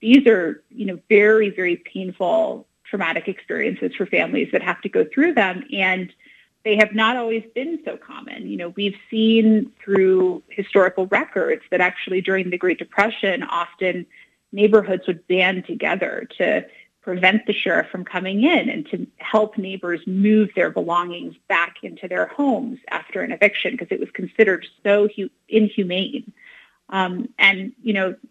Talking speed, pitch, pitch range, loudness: 155 wpm, 200 Hz, 185-225 Hz, -20 LUFS